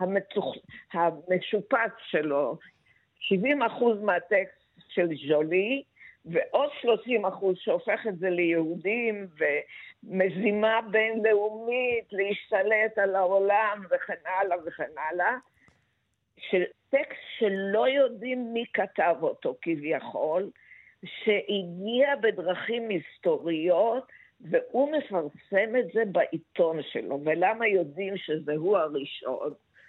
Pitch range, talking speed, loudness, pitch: 180-235 Hz, 90 wpm, -27 LUFS, 205 Hz